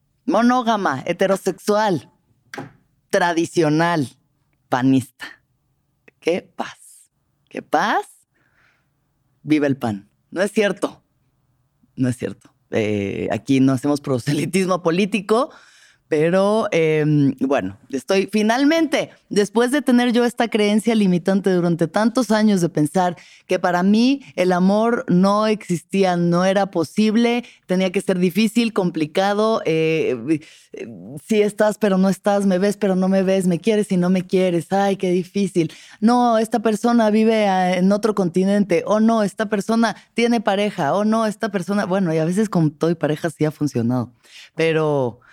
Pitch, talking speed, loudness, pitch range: 190 Hz, 145 wpm, -19 LUFS, 155-215 Hz